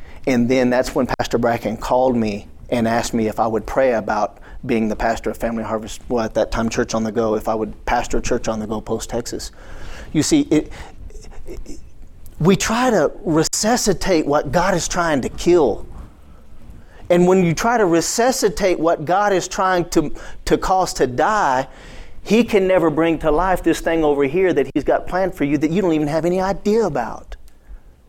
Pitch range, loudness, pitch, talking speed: 115-185 Hz, -18 LUFS, 155 Hz, 200 wpm